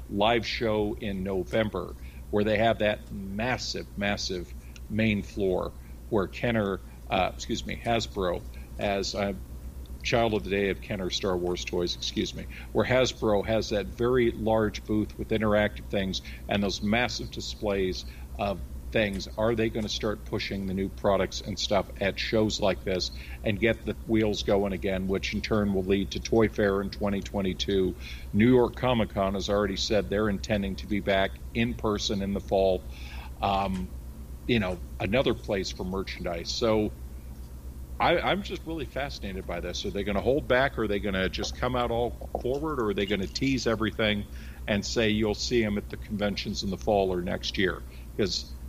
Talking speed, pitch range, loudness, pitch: 180 wpm, 90-110 Hz, -28 LUFS, 100 Hz